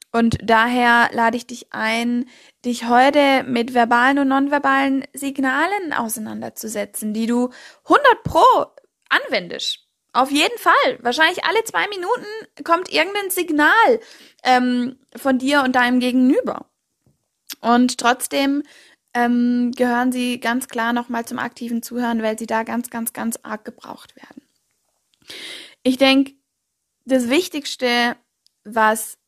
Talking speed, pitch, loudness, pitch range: 125 wpm, 250 Hz, -18 LUFS, 235-280 Hz